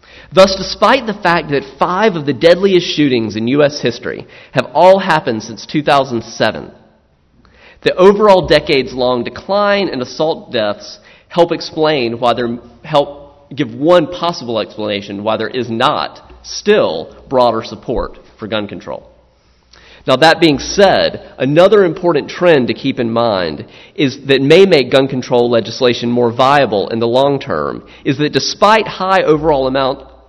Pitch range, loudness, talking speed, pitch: 120-170 Hz, -13 LUFS, 145 wpm, 135 Hz